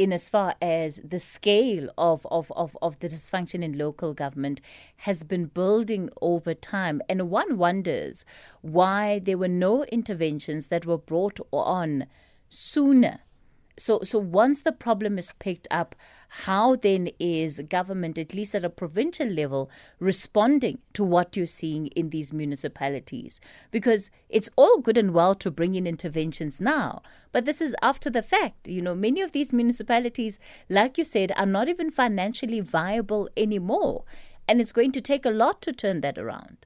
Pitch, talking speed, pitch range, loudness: 190 Hz, 165 wpm, 170-225 Hz, -25 LUFS